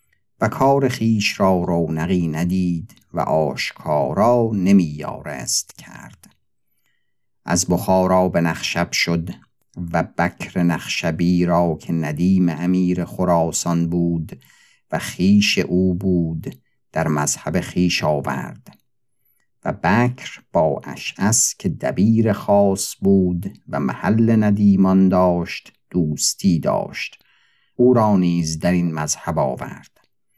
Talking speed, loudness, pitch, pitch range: 105 wpm, -19 LUFS, 90 Hz, 85-95 Hz